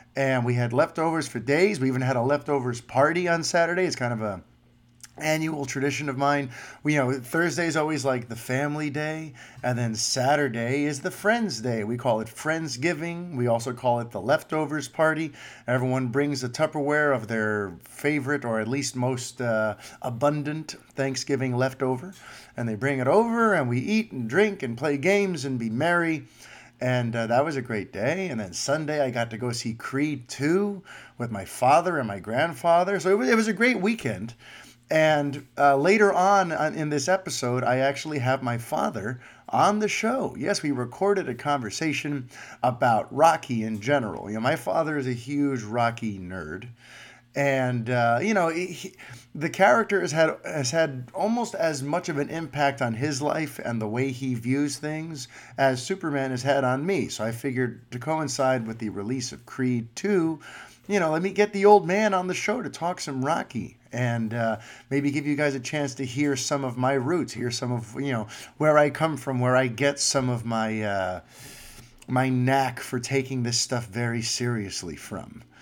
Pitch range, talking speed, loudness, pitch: 120-155 Hz, 195 wpm, -25 LUFS, 135 Hz